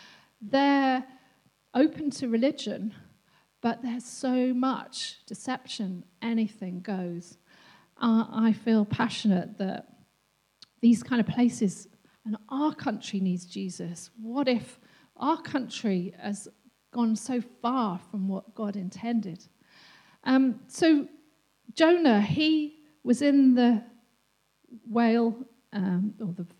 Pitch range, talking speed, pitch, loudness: 205-260 Hz, 110 wpm, 235 Hz, -27 LUFS